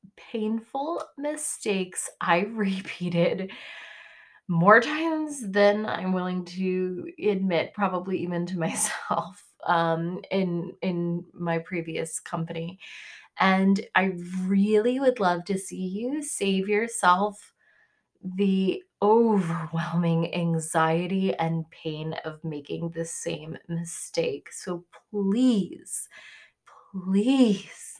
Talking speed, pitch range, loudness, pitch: 95 wpm, 170-210 Hz, -26 LUFS, 185 Hz